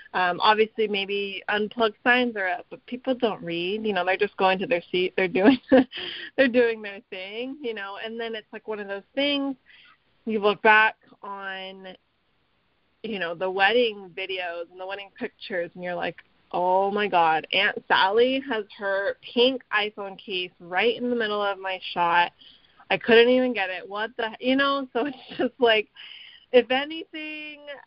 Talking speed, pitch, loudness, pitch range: 180 wpm, 215 Hz, -24 LUFS, 190-245 Hz